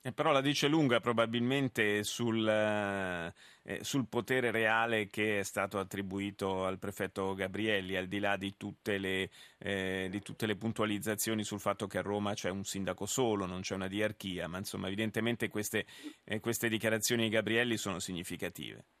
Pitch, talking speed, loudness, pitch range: 105 Hz, 165 wpm, -34 LUFS, 95-115 Hz